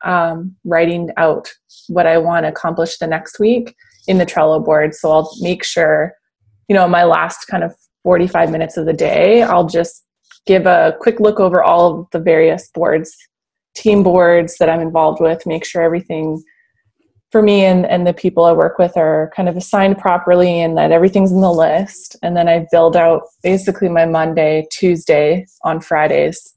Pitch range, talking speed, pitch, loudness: 165-185 Hz, 185 wpm, 170 Hz, -13 LUFS